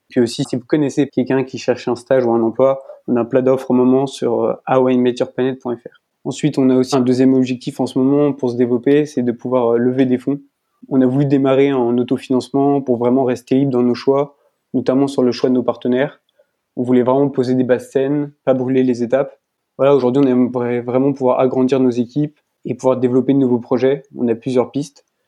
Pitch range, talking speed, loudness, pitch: 125-135 Hz, 215 wpm, -16 LUFS, 130 Hz